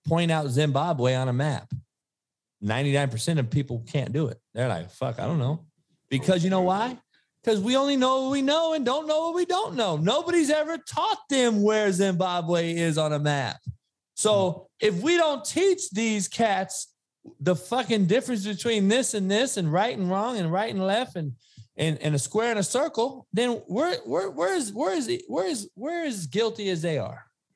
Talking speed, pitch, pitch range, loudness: 205 wpm, 195 Hz, 155-255 Hz, -25 LUFS